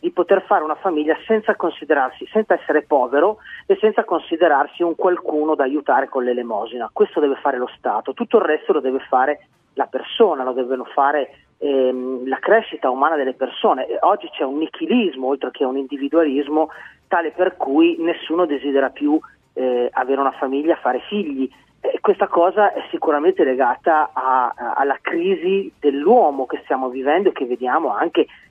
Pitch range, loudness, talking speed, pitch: 135-200 Hz, -19 LUFS, 170 wpm, 155 Hz